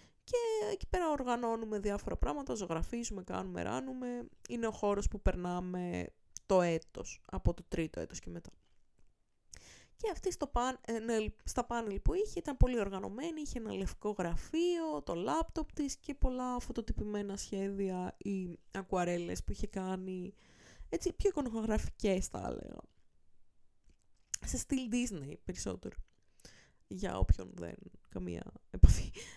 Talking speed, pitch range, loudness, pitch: 130 wpm, 175-255 Hz, -37 LUFS, 205 Hz